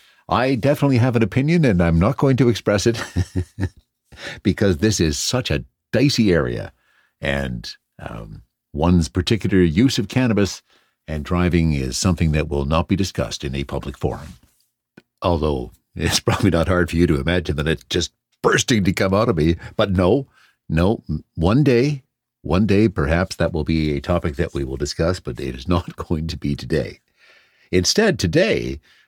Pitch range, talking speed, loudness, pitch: 80-110 Hz, 175 wpm, -20 LUFS, 90 Hz